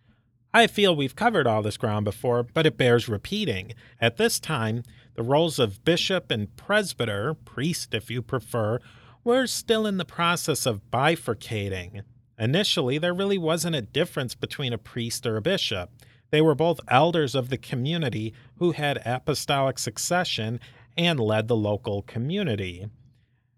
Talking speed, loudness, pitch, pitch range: 155 wpm, -25 LUFS, 125 Hz, 115-160 Hz